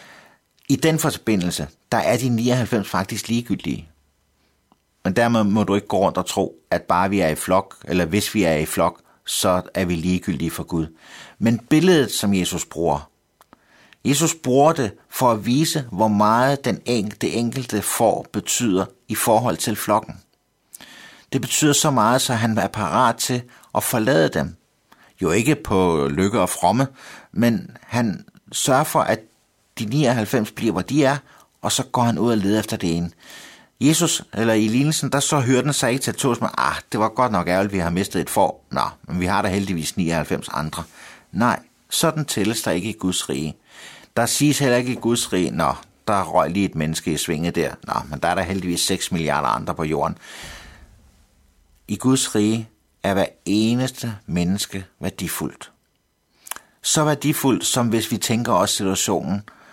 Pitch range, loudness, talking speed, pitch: 90-125 Hz, -21 LUFS, 185 wpm, 110 Hz